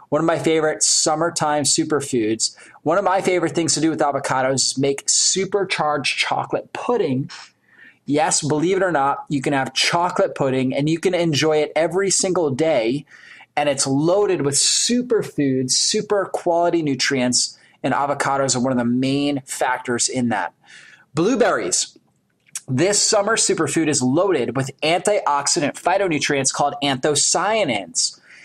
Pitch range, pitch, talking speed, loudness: 135-170 Hz, 150 Hz, 140 wpm, -19 LUFS